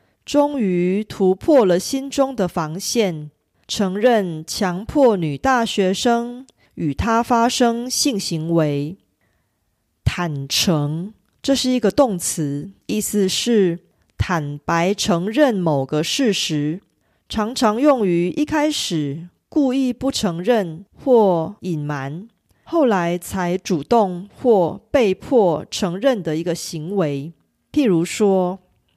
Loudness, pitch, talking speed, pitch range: -19 LUFS, 190 Hz, 160 characters per minute, 165-235 Hz